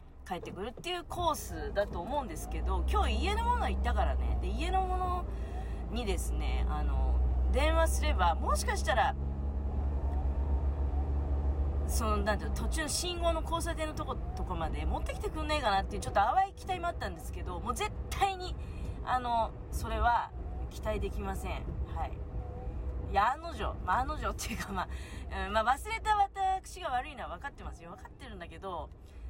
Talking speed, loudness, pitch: 350 characters per minute, -34 LUFS, 70 Hz